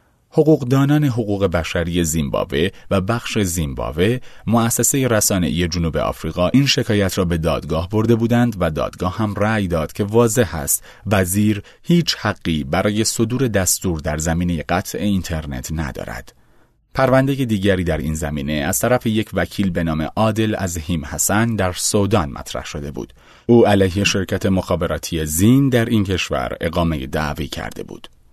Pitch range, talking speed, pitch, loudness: 80-115 Hz, 150 wpm, 95 Hz, -18 LUFS